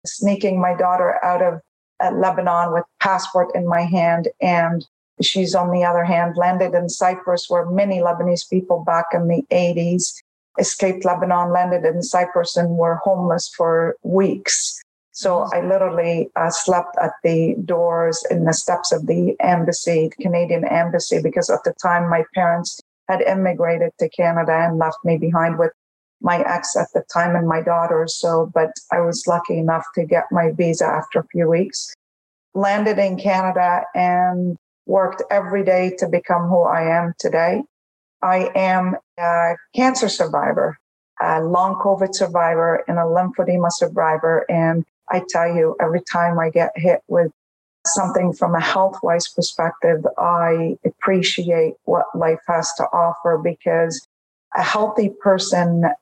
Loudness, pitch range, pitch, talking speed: -19 LUFS, 170-185 Hz, 175 Hz, 155 wpm